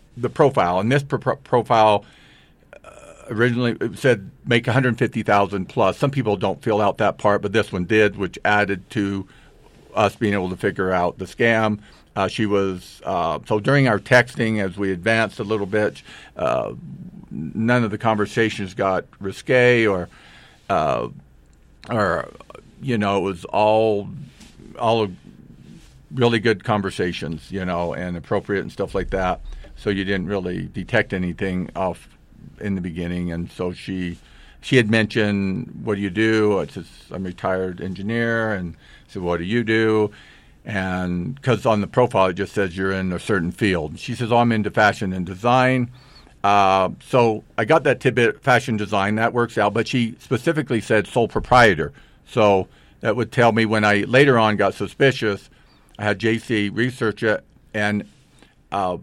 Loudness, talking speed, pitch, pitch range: -20 LUFS, 170 wpm, 105 Hz, 95-115 Hz